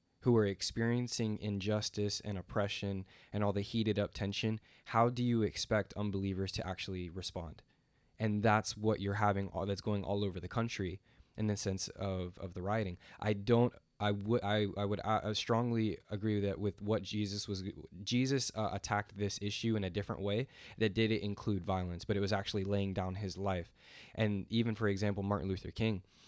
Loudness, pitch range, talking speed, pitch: -36 LUFS, 100-110 Hz, 185 wpm, 105 Hz